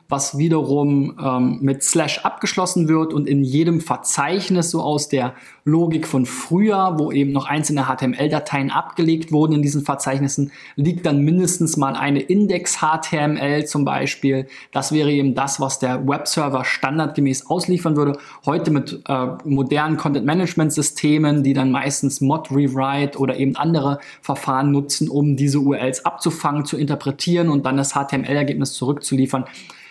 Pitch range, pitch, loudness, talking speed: 135-155 Hz, 145 Hz, -19 LUFS, 145 wpm